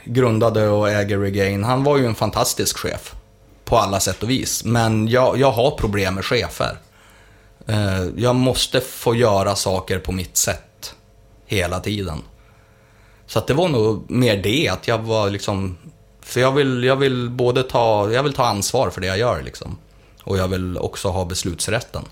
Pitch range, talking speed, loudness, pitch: 95-115 Hz, 180 wpm, -19 LUFS, 110 Hz